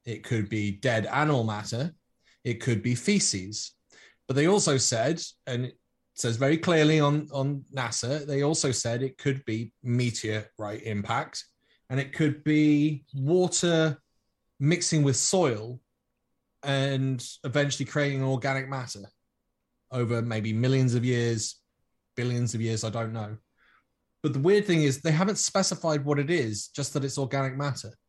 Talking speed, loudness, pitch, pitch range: 150 wpm, -27 LUFS, 135 Hz, 115-150 Hz